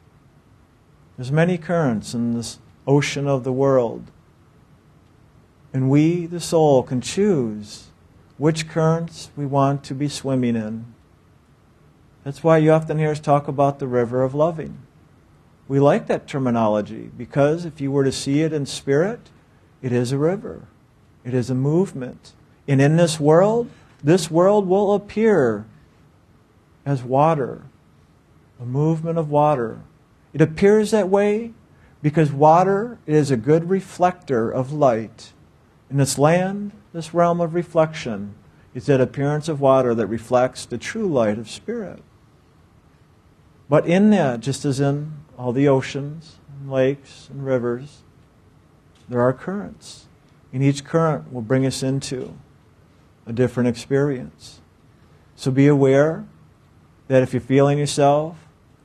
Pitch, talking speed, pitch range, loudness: 140 Hz, 140 wpm, 125-160 Hz, -20 LUFS